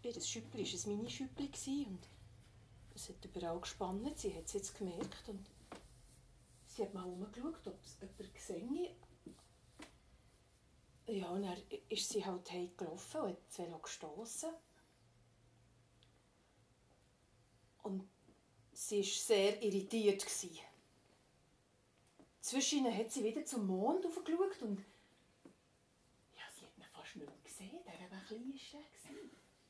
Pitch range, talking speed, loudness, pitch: 170-255 Hz, 125 wpm, -42 LUFS, 200 Hz